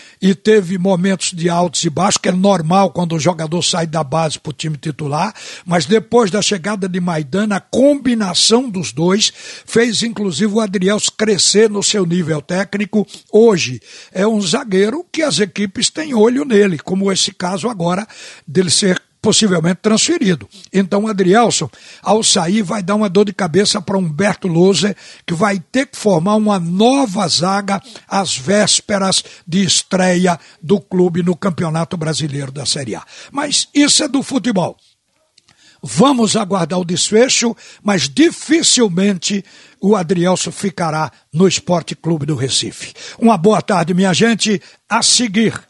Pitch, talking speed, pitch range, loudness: 195 Hz, 155 wpm, 175-215 Hz, -15 LUFS